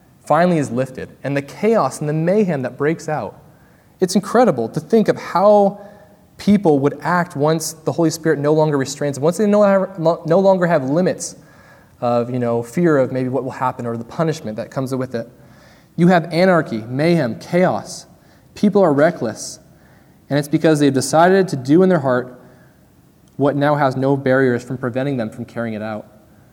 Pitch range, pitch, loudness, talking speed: 130-170 Hz, 150 Hz, -17 LUFS, 185 wpm